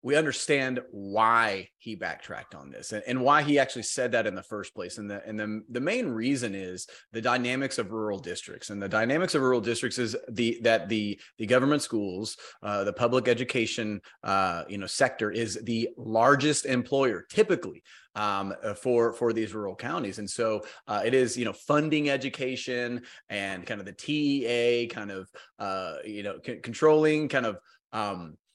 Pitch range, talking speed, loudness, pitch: 105-130 Hz, 185 wpm, -28 LUFS, 120 Hz